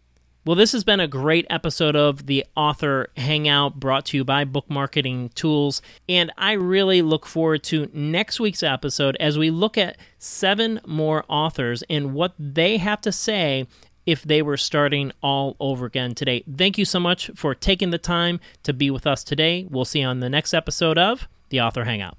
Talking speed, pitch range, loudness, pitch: 195 wpm, 140-175 Hz, -21 LUFS, 150 Hz